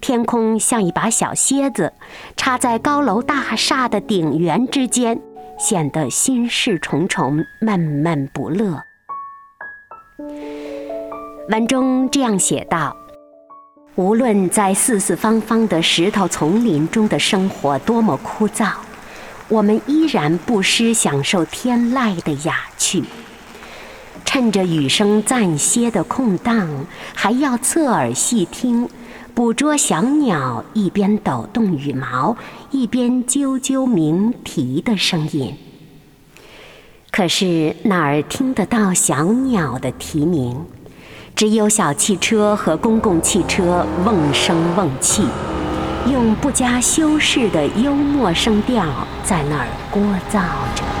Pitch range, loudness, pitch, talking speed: 165-245 Hz, -17 LUFS, 215 Hz, 170 characters per minute